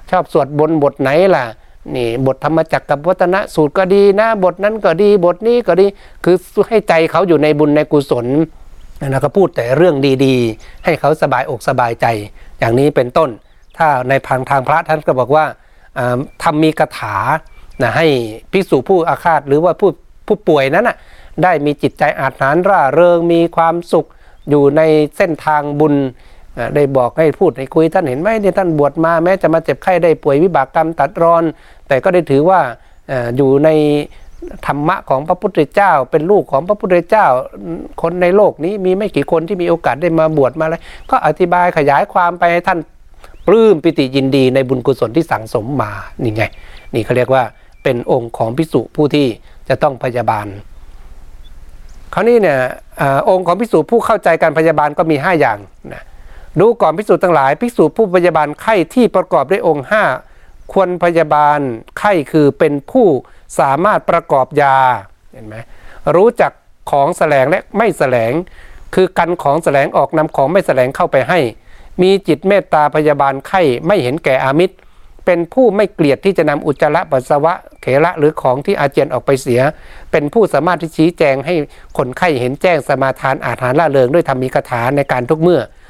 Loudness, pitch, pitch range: -13 LUFS, 150 Hz, 135-175 Hz